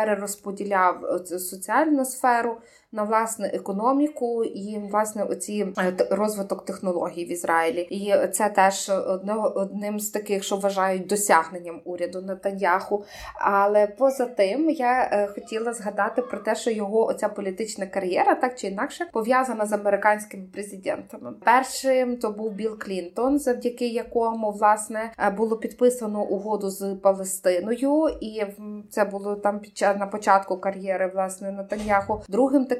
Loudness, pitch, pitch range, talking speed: -24 LUFS, 205 Hz, 195-230 Hz, 130 wpm